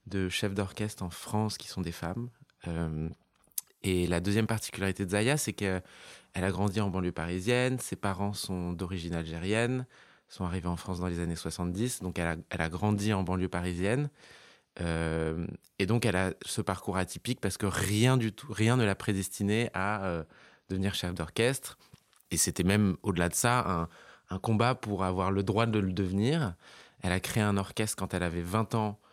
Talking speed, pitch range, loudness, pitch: 190 wpm, 90-110 Hz, -31 LUFS, 95 Hz